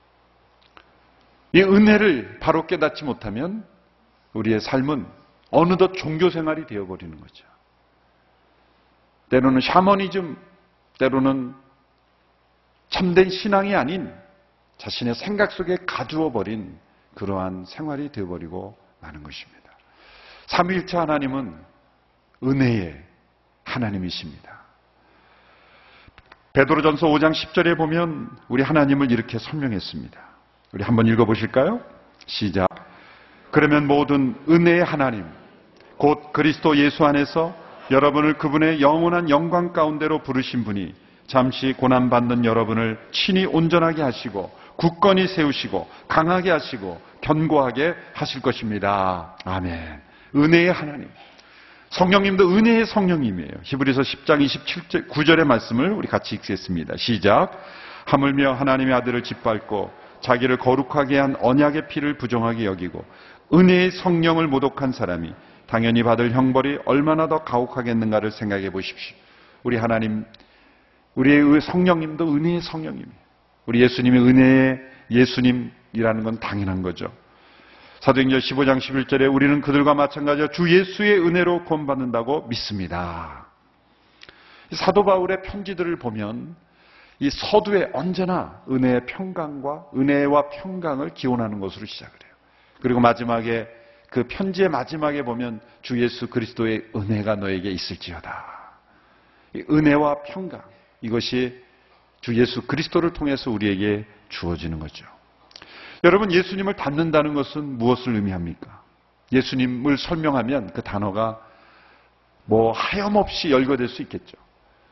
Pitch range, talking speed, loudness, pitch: 110-155 Hz, 290 characters per minute, -21 LUFS, 130 Hz